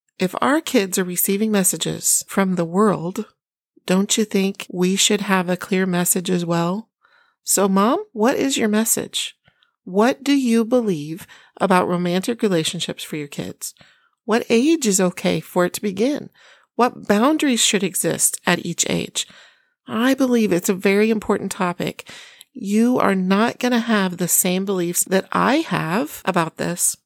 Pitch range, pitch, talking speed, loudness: 180-230 Hz, 200 Hz, 160 wpm, -19 LUFS